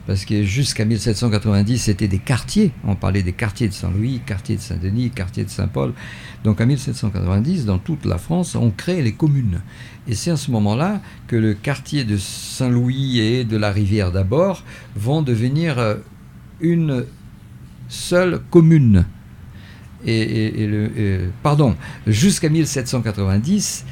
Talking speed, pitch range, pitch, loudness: 145 wpm, 100-135 Hz, 110 Hz, -19 LUFS